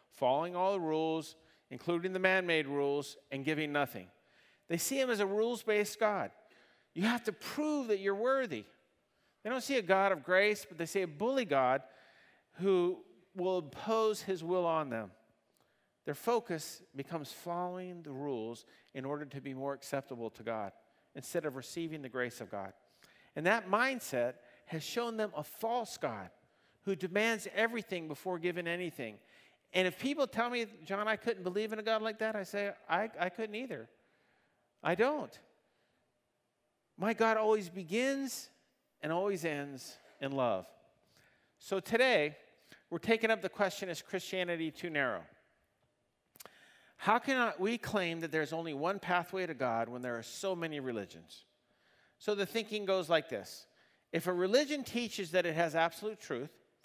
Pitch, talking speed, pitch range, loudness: 180 Hz, 165 wpm, 150-215 Hz, -35 LUFS